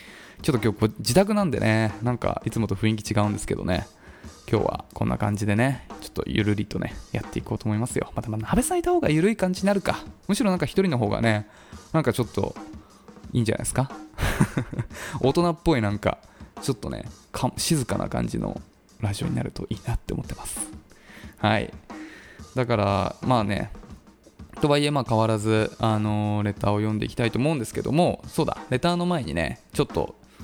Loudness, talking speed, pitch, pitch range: -25 LUFS, 390 characters per minute, 110 Hz, 105-150 Hz